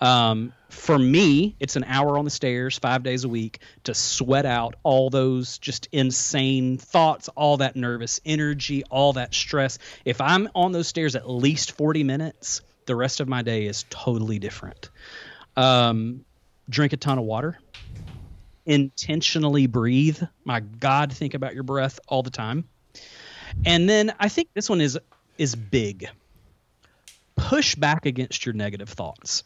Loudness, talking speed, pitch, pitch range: -23 LUFS, 155 wpm, 135 Hz, 120-150 Hz